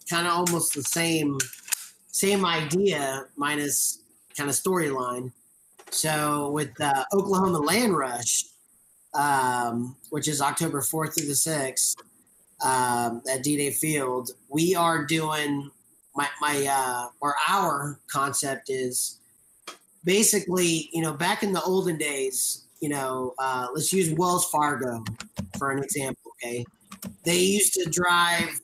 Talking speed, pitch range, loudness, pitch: 130 wpm, 130-170 Hz, -25 LUFS, 145 Hz